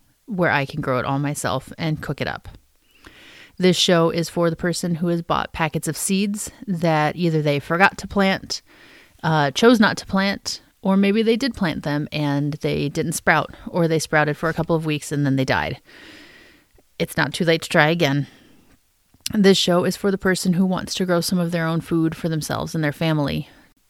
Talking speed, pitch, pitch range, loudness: 210 wpm, 165 Hz, 150-185 Hz, -21 LUFS